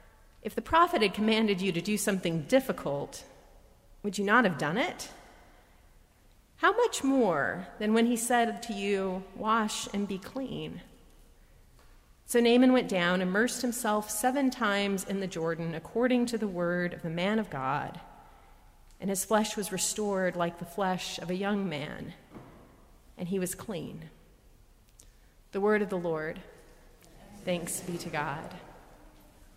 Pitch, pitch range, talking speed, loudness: 200 Hz, 180-225 Hz, 150 wpm, -29 LUFS